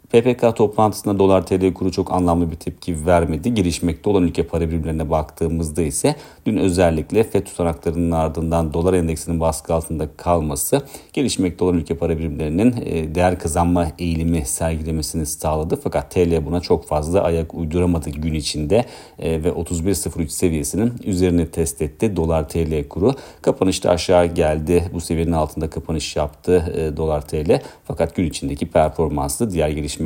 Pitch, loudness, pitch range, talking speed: 85 Hz, -20 LUFS, 80-90 Hz, 140 wpm